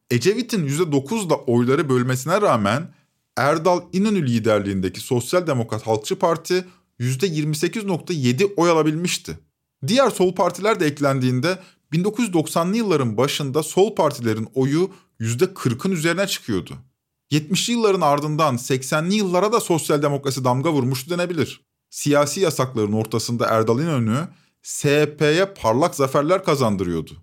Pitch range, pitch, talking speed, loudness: 125-180 Hz, 150 Hz, 110 wpm, -20 LUFS